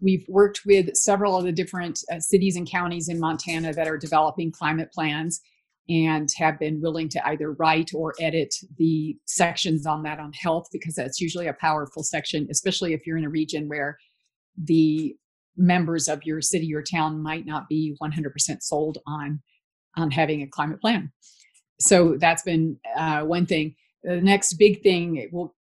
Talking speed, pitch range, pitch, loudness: 175 wpm, 155-175 Hz, 160 Hz, -24 LUFS